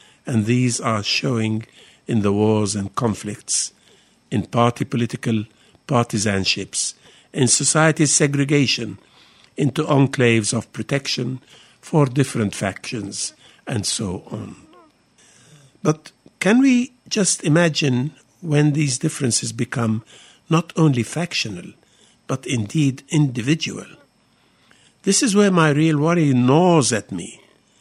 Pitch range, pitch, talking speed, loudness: 115-155 Hz, 135 Hz, 110 wpm, -19 LUFS